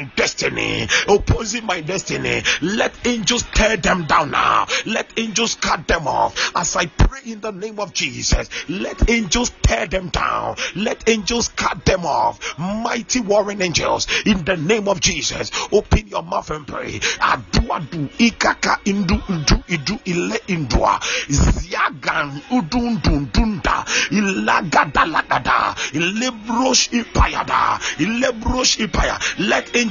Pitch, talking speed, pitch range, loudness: 215 Hz, 95 wpm, 185-235 Hz, -18 LUFS